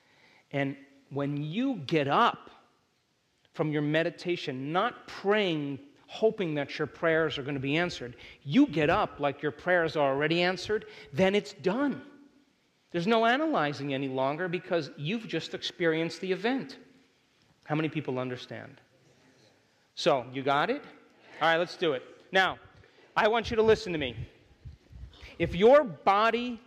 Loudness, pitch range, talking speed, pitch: -29 LUFS, 140-200 Hz, 150 wpm, 165 Hz